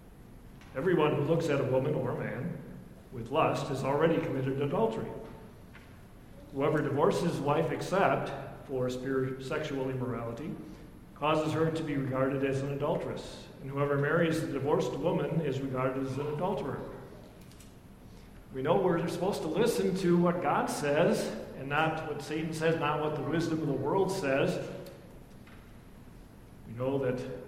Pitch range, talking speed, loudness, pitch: 135-160 Hz, 150 wpm, -31 LUFS, 145 Hz